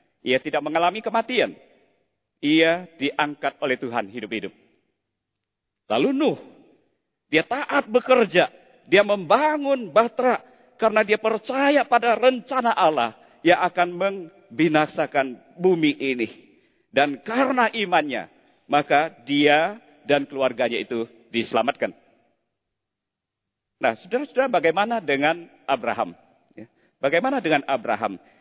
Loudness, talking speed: -22 LUFS, 95 wpm